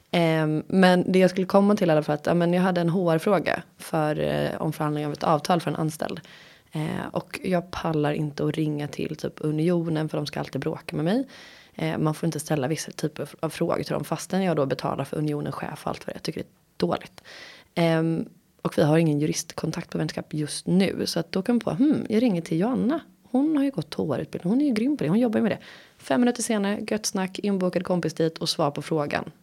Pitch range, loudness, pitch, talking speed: 155-195 Hz, -25 LUFS, 170 Hz, 230 wpm